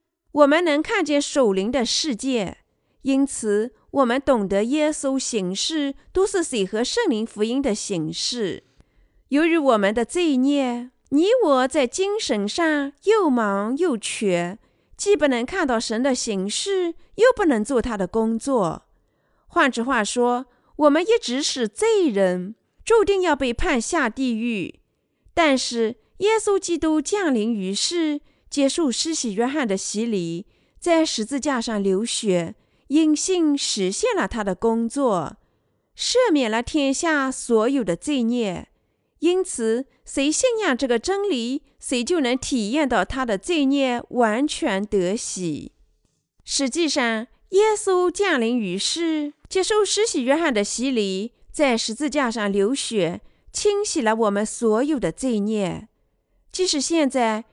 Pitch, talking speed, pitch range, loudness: 265 Hz, 200 characters per minute, 225-315 Hz, -22 LUFS